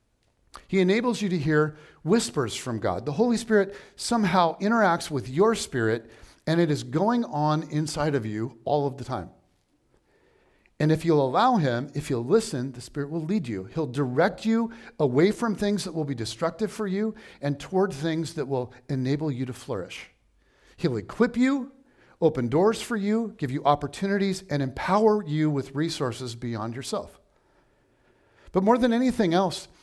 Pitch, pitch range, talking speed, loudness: 155 Hz, 135-205 Hz, 170 wpm, -26 LUFS